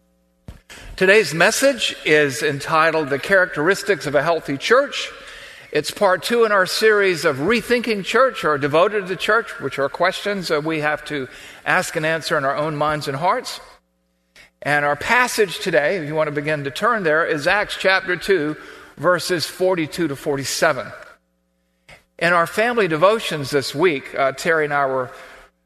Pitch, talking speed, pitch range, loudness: 155 Hz, 165 wpm, 140-195 Hz, -19 LUFS